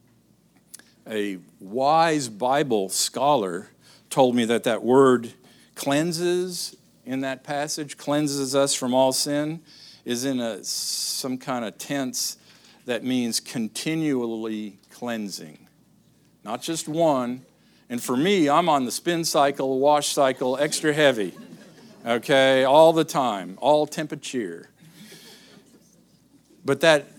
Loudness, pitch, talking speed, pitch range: -23 LUFS, 140 Hz, 115 wpm, 125-155 Hz